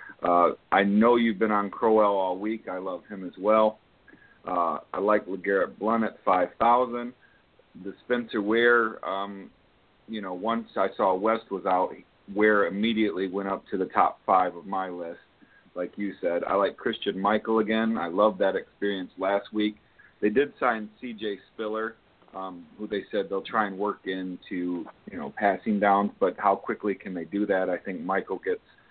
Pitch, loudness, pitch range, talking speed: 105 Hz, -26 LUFS, 95-110 Hz, 180 wpm